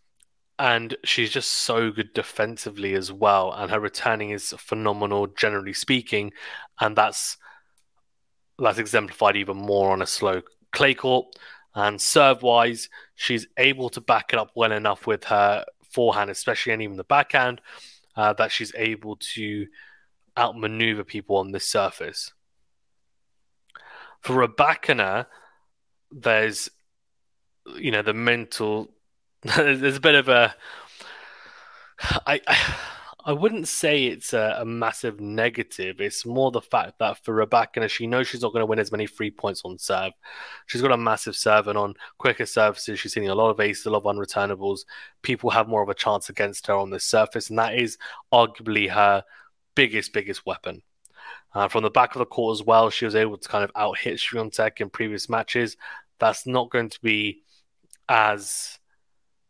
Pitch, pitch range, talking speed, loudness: 110 Hz, 100-120 Hz, 165 wpm, -23 LUFS